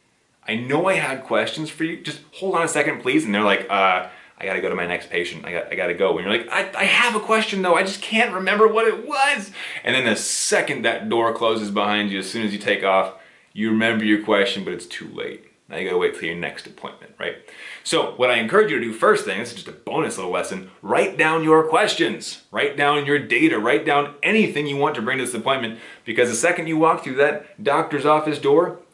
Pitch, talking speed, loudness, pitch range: 155 Hz, 250 wpm, -20 LUFS, 130-210 Hz